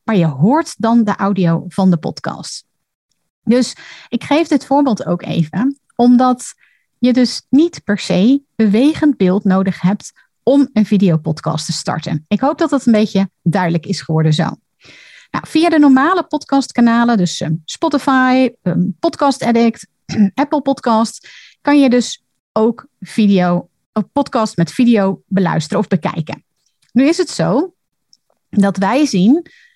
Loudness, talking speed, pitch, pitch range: -15 LUFS, 140 wpm, 225 Hz, 190-275 Hz